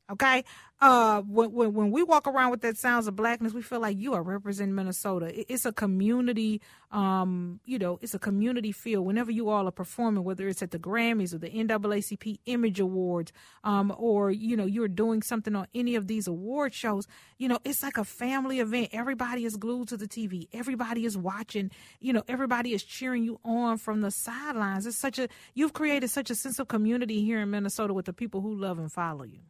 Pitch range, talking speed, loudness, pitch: 200-240 Hz, 215 wpm, -29 LUFS, 220 Hz